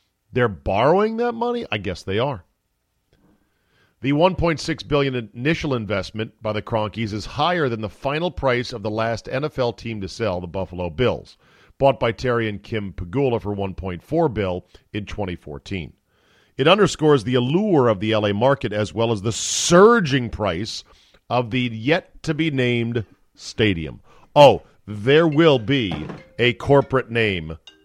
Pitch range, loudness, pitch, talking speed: 105-140 Hz, -21 LUFS, 115 Hz, 155 wpm